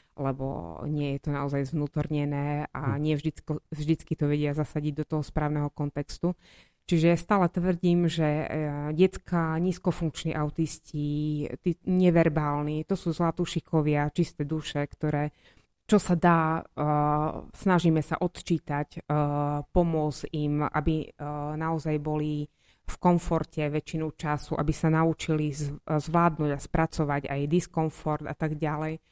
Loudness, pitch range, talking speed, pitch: -28 LUFS, 150-165 Hz, 115 wpm, 155 Hz